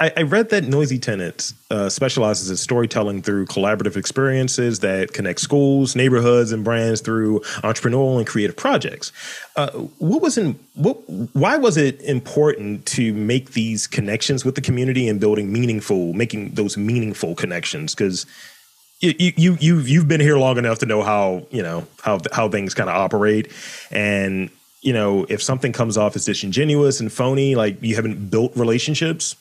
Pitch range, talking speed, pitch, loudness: 105-140 Hz, 165 wpm, 120 Hz, -19 LUFS